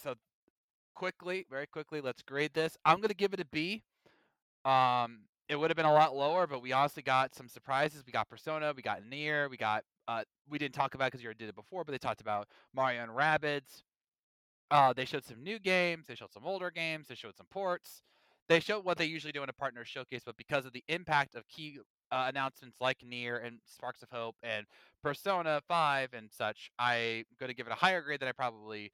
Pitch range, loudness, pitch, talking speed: 120-155 Hz, -34 LUFS, 135 Hz, 230 wpm